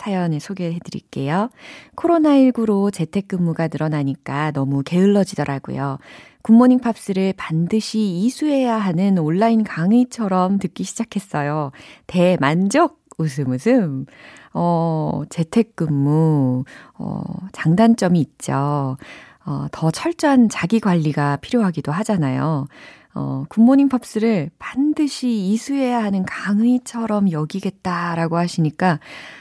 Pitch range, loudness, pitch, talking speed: 155-225 Hz, -19 LUFS, 185 Hz, 265 characters per minute